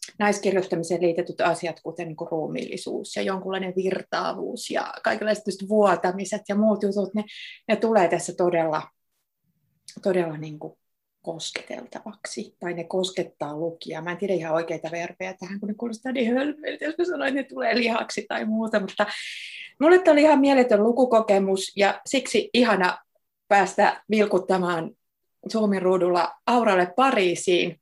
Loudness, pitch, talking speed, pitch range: -24 LUFS, 195 Hz, 140 wpm, 175-220 Hz